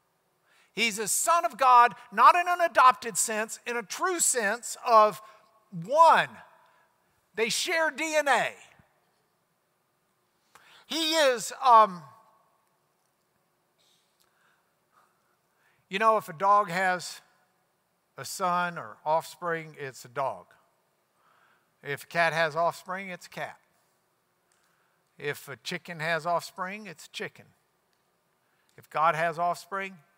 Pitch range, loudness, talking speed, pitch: 170-240 Hz, -25 LUFS, 110 wpm, 200 Hz